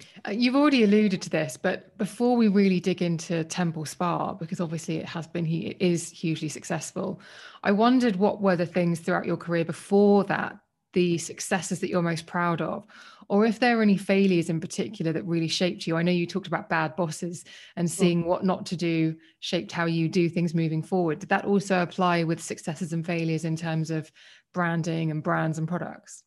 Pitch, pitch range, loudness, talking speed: 175 Hz, 165-190 Hz, -26 LUFS, 205 wpm